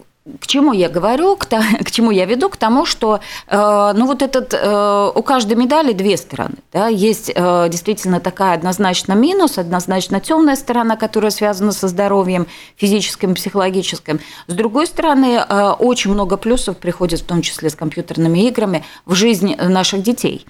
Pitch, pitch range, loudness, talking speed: 205 Hz, 185-230 Hz, -15 LUFS, 155 wpm